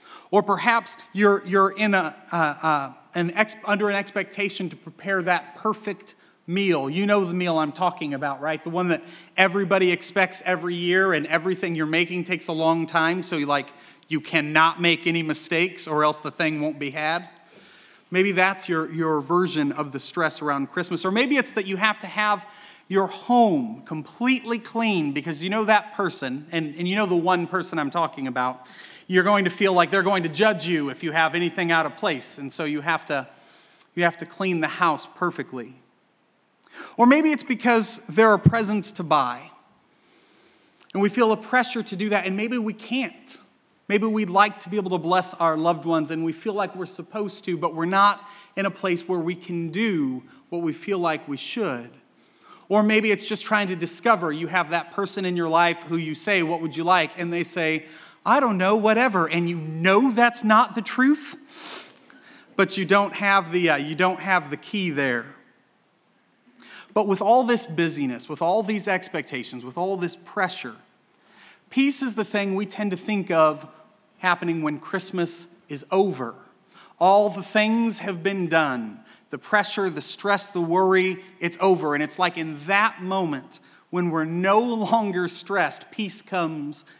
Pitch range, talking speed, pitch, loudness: 165-205 Hz, 190 wpm, 185 Hz, -23 LUFS